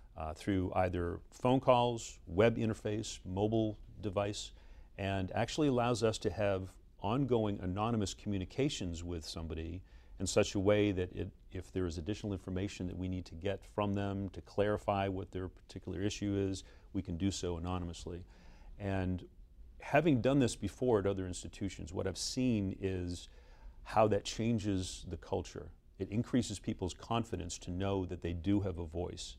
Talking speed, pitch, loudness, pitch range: 160 wpm, 95 Hz, -36 LUFS, 90-105 Hz